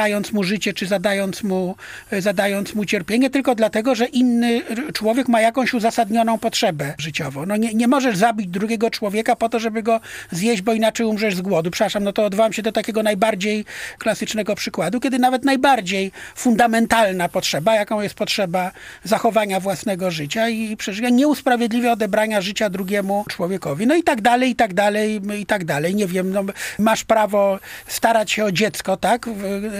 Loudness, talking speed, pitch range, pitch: -19 LUFS, 175 wpm, 200-230 Hz, 215 Hz